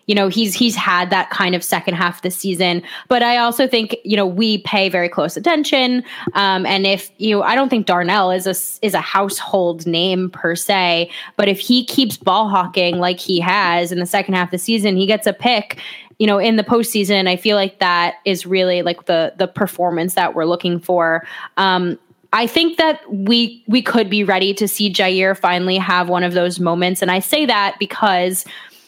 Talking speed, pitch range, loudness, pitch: 215 wpm, 180-215 Hz, -16 LUFS, 195 Hz